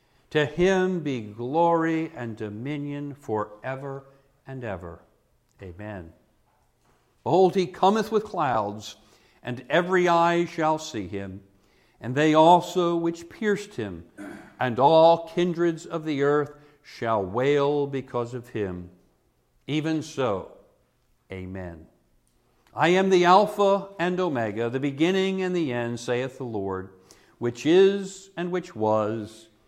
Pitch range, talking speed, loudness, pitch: 110-170 Hz, 120 wpm, -24 LUFS, 140 Hz